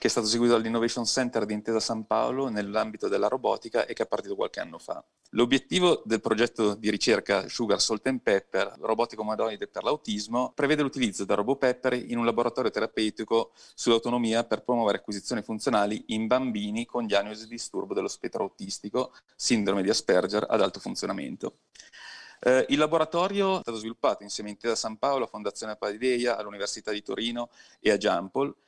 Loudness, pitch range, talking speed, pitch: -27 LUFS, 110-125 Hz, 170 wpm, 115 Hz